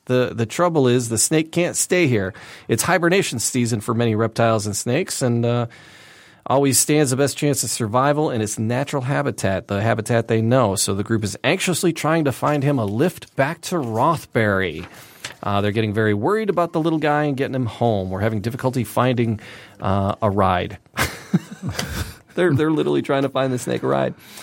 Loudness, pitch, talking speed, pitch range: -20 LUFS, 120 Hz, 190 wpm, 110-145 Hz